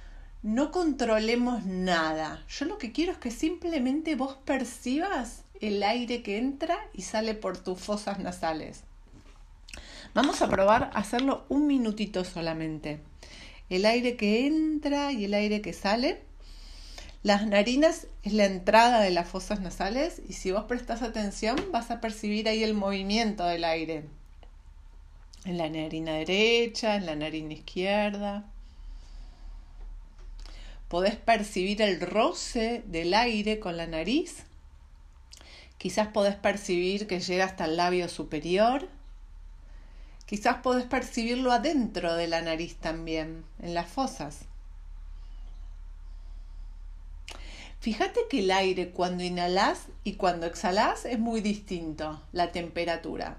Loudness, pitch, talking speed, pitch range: -28 LUFS, 190 Hz, 125 wpm, 155-230 Hz